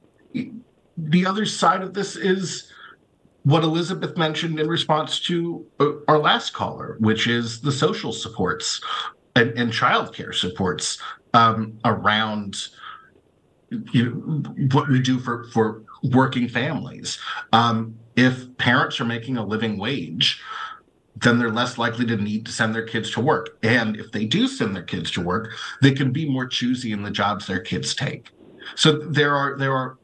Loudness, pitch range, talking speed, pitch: -22 LUFS, 115-155 Hz, 160 wpm, 130 Hz